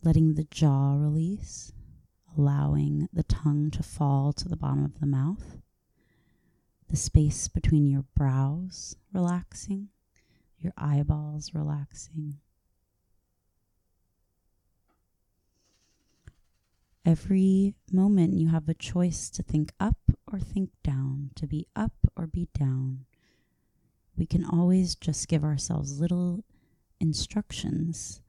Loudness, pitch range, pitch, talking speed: -28 LUFS, 110-165 Hz, 150 Hz, 105 wpm